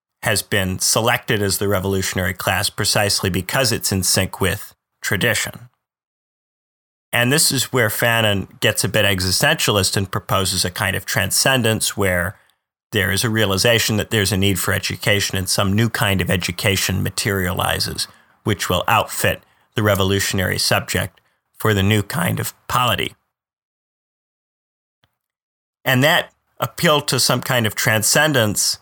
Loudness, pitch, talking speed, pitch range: -18 LUFS, 105 Hz, 140 wpm, 95-120 Hz